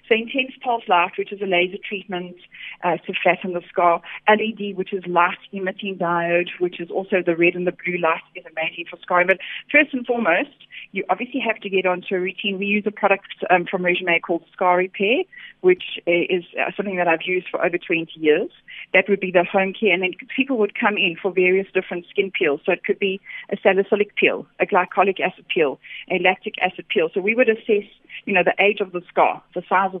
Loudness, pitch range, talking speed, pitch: -20 LUFS, 180-205 Hz, 220 wpm, 185 Hz